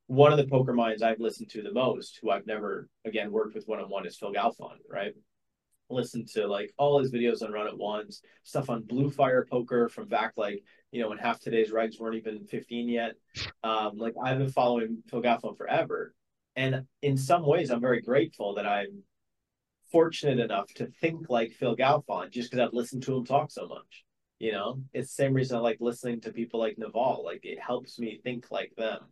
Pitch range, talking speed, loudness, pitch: 115-130 Hz, 210 wpm, -30 LUFS, 120 Hz